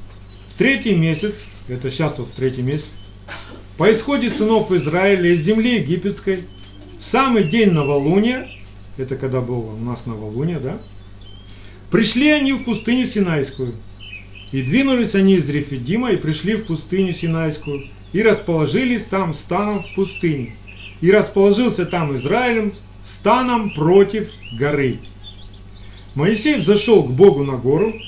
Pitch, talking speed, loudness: 160 Hz, 125 wpm, -18 LUFS